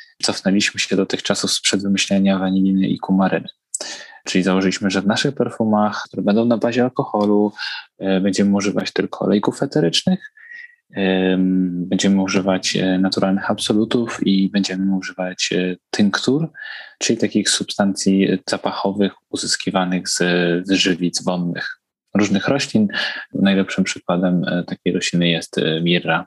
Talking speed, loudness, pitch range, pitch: 115 wpm, -19 LUFS, 95-105 Hz, 95 Hz